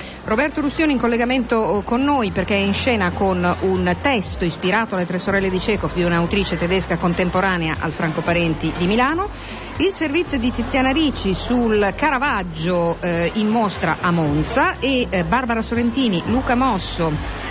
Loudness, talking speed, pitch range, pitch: -19 LUFS, 160 wpm, 180-250 Hz, 200 Hz